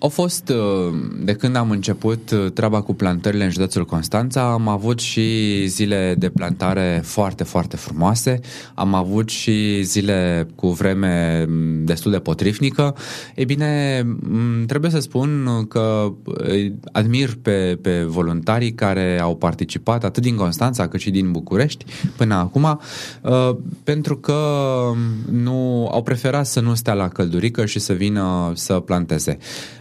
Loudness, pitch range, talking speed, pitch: -19 LUFS, 95-125 Hz, 135 wpm, 105 Hz